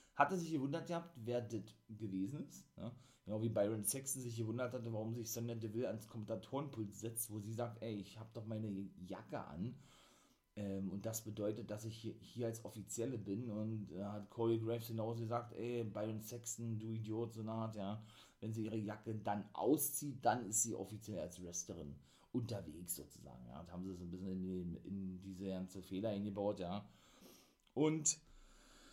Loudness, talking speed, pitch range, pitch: -43 LUFS, 185 wpm, 100-115 Hz, 110 Hz